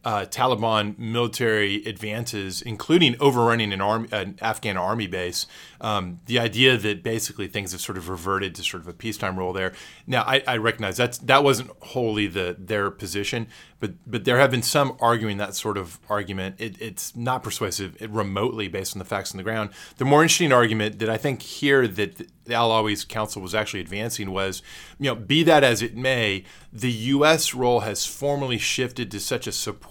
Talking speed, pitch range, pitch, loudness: 195 wpm, 100-125 Hz, 110 Hz, -23 LUFS